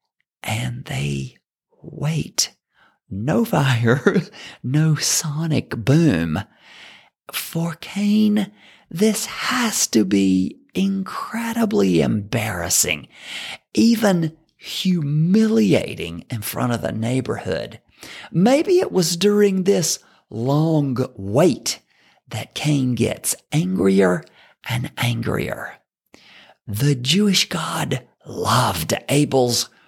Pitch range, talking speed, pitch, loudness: 120-195 Hz, 80 wpm, 150 Hz, -20 LUFS